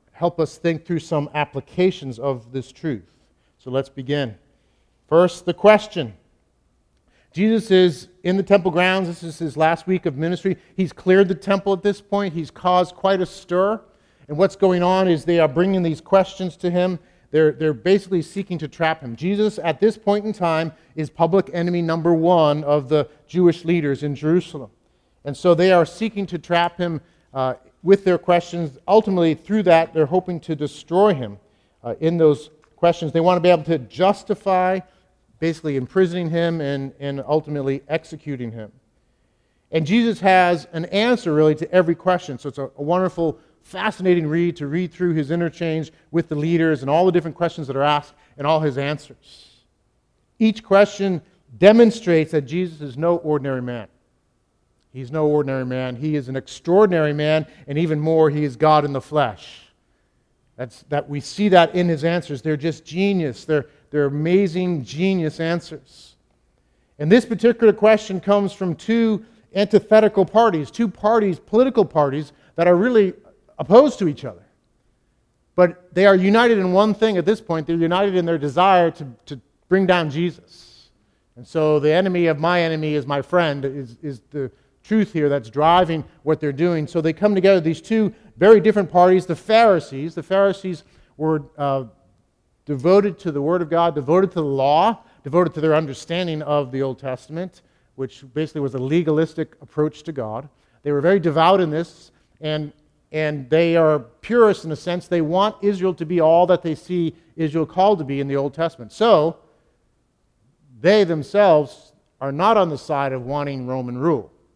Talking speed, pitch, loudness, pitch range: 180 wpm, 165 Hz, -19 LUFS, 145-185 Hz